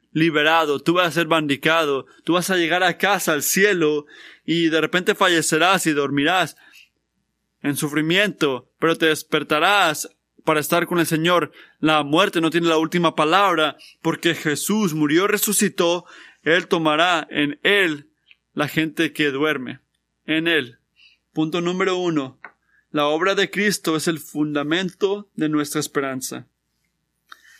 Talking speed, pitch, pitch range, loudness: 140 wpm, 160 Hz, 150-175 Hz, -20 LUFS